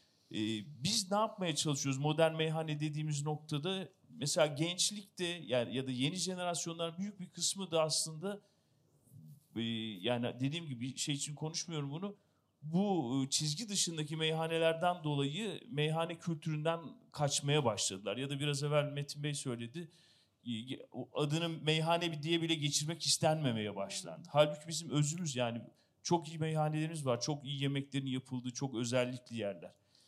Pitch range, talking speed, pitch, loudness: 135-165 Hz, 130 wpm, 150 Hz, -36 LUFS